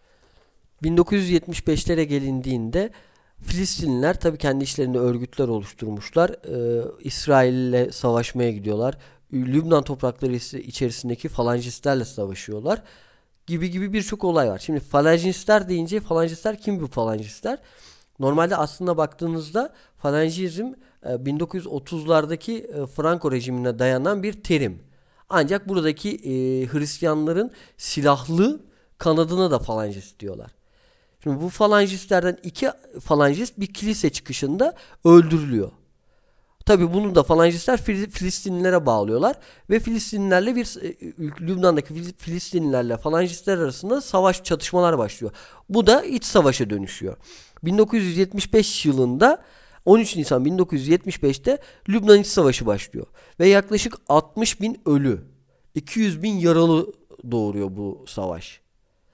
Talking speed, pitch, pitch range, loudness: 100 wpm, 160 Hz, 130-190 Hz, -21 LUFS